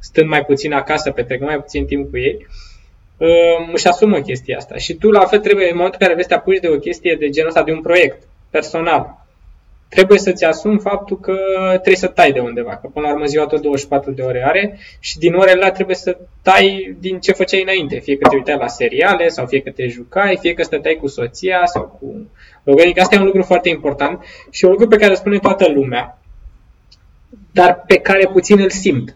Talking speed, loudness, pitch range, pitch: 220 wpm, -14 LUFS, 140-195 Hz, 180 Hz